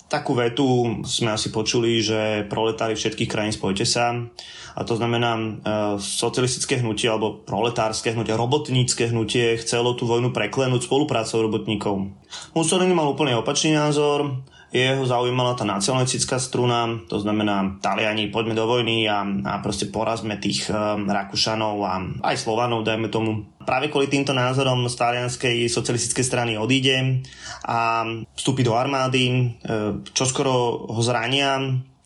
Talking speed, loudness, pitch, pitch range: 135 wpm, -22 LUFS, 120 Hz, 110-130 Hz